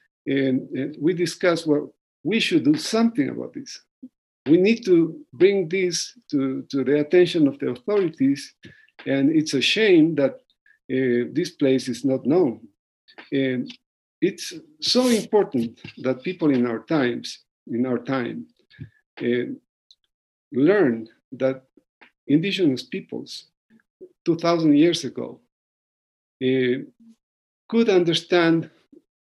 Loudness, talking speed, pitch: -22 LUFS, 115 wpm, 170 Hz